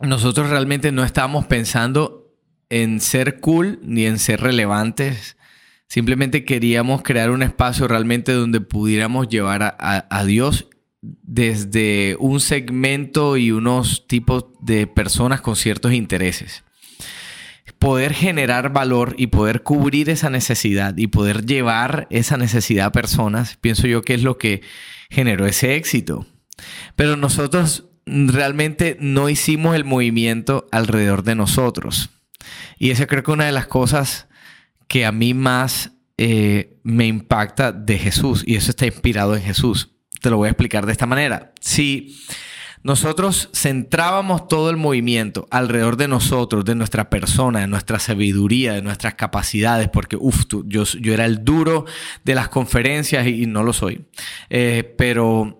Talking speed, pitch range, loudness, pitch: 150 wpm, 110-140 Hz, -18 LUFS, 120 Hz